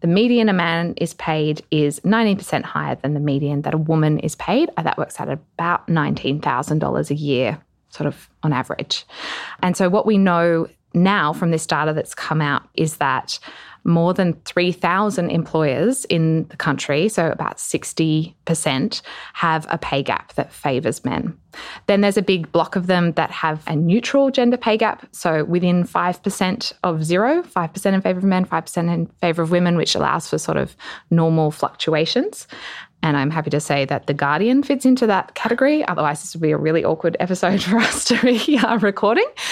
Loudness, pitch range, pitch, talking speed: -19 LUFS, 155-200 Hz, 170 Hz, 185 wpm